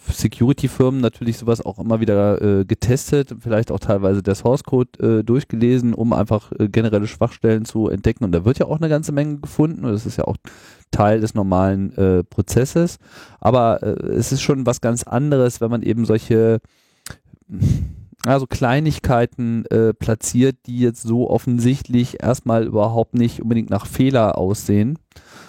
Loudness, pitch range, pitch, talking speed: -18 LUFS, 105-125 Hz, 115 Hz, 160 wpm